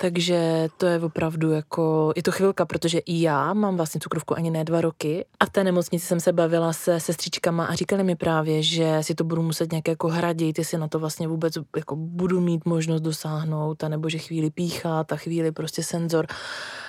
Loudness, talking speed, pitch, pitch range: -24 LUFS, 205 wpm, 165 Hz, 160-175 Hz